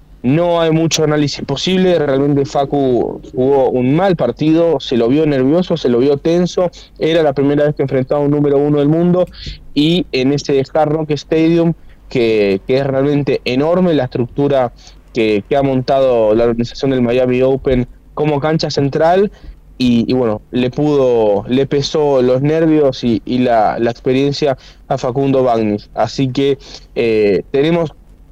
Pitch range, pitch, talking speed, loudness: 125-150 Hz, 140 Hz, 160 wpm, -14 LUFS